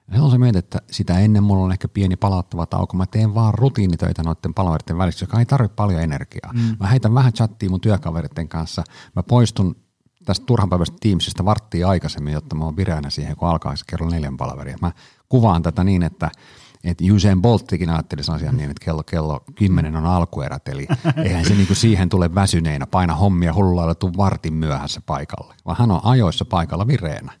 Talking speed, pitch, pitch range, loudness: 195 wpm, 95 Hz, 85-105 Hz, -19 LUFS